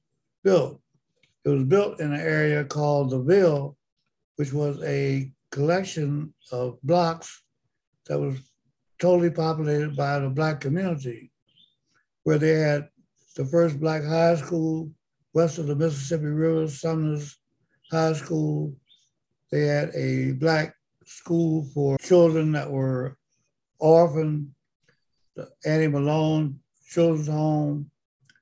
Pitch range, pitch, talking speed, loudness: 140-160 Hz, 150 Hz, 115 wpm, -24 LUFS